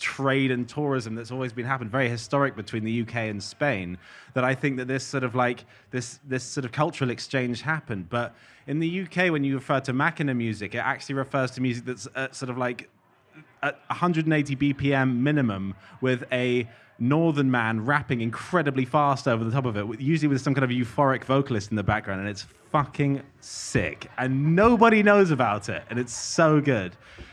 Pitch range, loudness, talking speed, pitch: 120-140 Hz, -25 LUFS, 190 wpm, 130 Hz